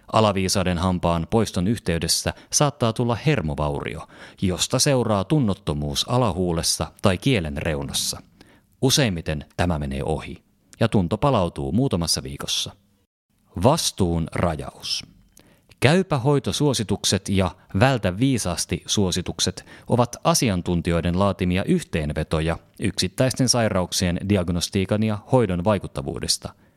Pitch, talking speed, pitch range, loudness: 95 Hz, 90 wpm, 85-115 Hz, -22 LUFS